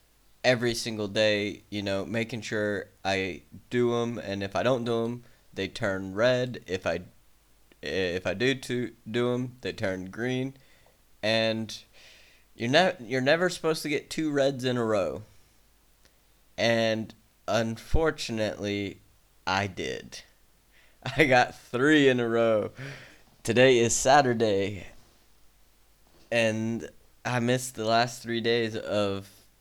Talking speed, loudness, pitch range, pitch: 130 wpm, -27 LUFS, 105-125 Hz, 115 Hz